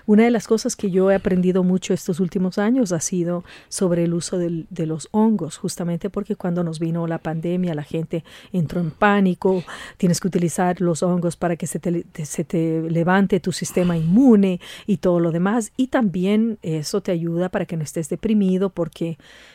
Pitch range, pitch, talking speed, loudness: 170-200 Hz, 180 Hz, 195 wpm, -21 LUFS